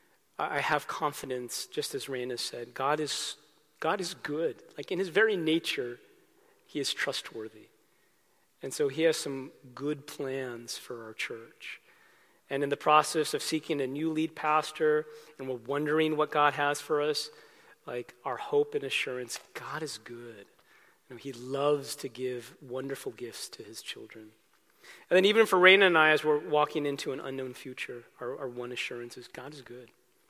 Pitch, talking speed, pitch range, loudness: 150 Hz, 175 wpm, 130-165 Hz, -30 LUFS